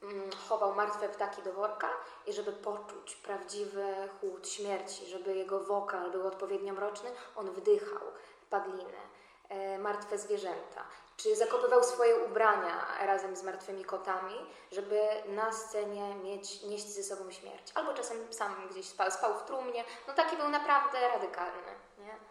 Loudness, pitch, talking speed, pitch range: -35 LUFS, 205 Hz, 140 wpm, 195-225 Hz